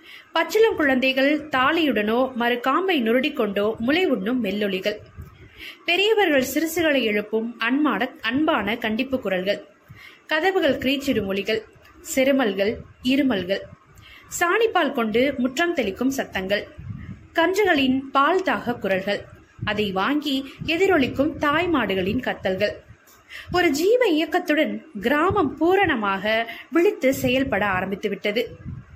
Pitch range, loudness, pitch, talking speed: 220-325 Hz, -22 LUFS, 265 Hz, 85 wpm